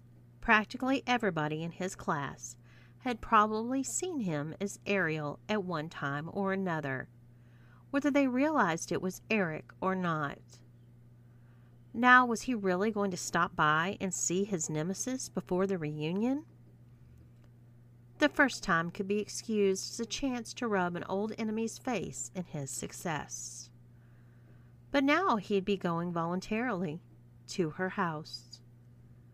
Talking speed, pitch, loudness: 135 wpm, 175 Hz, -32 LUFS